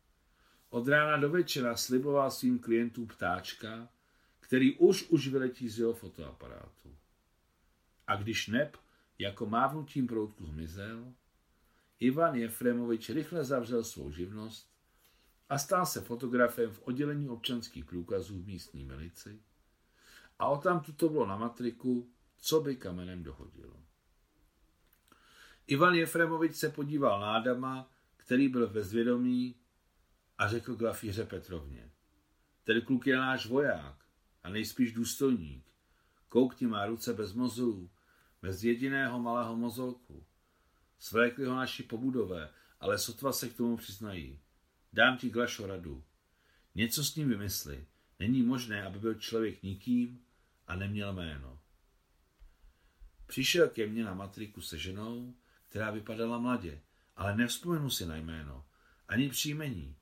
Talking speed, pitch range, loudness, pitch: 125 wpm, 85-125 Hz, -33 LUFS, 115 Hz